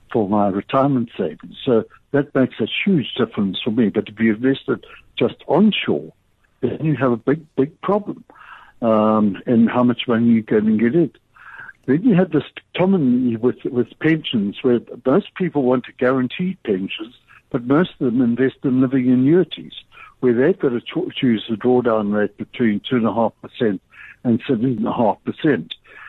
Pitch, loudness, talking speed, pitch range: 125 Hz, -19 LUFS, 160 wpm, 115-145 Hz